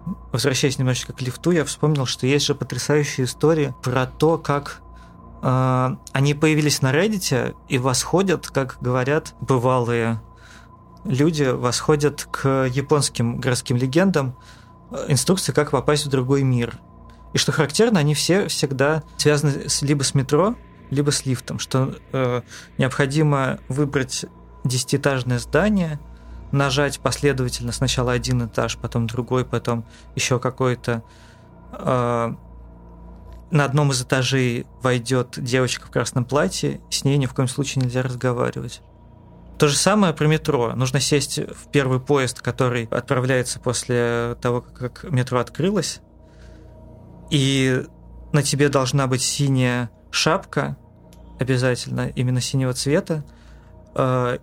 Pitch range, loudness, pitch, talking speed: 120-145 Hz, -21 LUFS, 130 Hz, 125 wpm